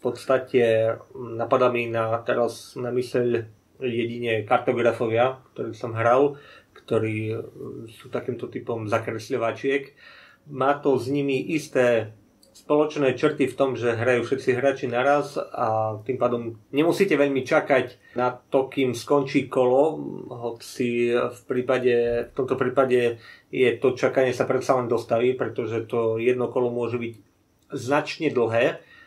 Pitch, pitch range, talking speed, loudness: 125 Hz, 115-135 Hz, 130 wpm, -24 LUFS